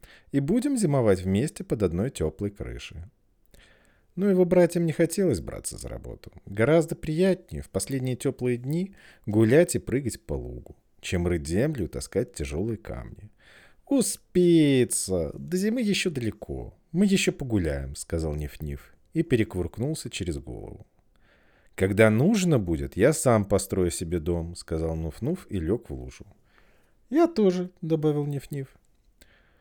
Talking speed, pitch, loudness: 140 wpm, 120 Hz, -26 LUFS